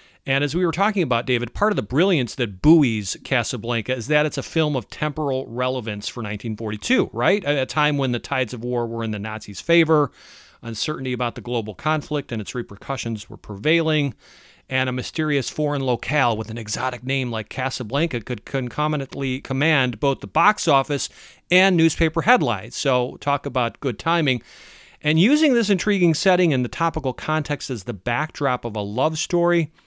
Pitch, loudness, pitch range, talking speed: 135 Hz, -22 LUFS, 120-155 Hz, 180 wpm